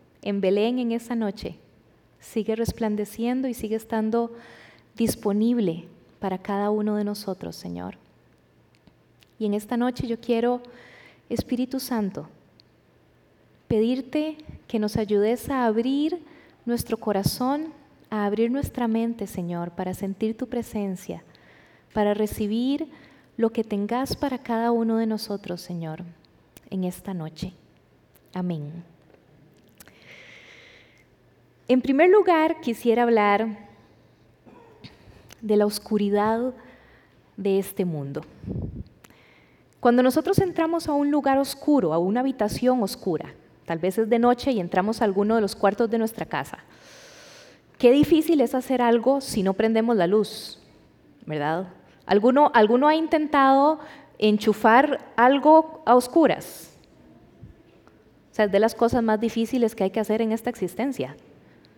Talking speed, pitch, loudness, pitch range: 125 wpm, 225 Hz, -23 LUFS, 205-255 Hz